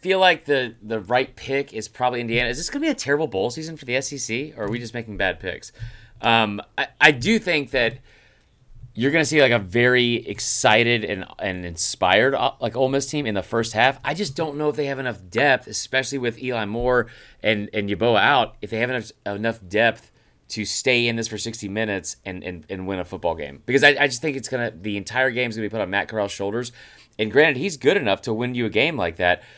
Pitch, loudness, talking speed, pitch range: 120 Hz, -21 LUFS, 245 wpm, 105-130 Hz